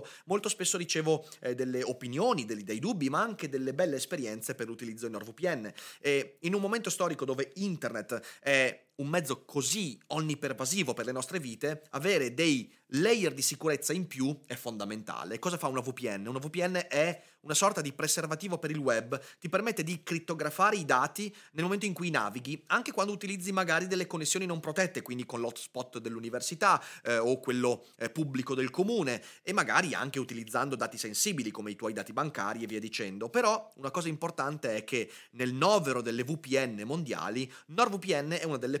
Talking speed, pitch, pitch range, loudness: 180 wpm, 150 Hz, 125-180 Hz, -32 LUFS